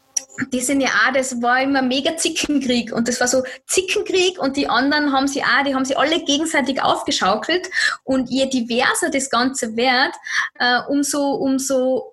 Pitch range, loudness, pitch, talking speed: 255-295 Hz, -18 LUFS, 270 Hz, 175 wpm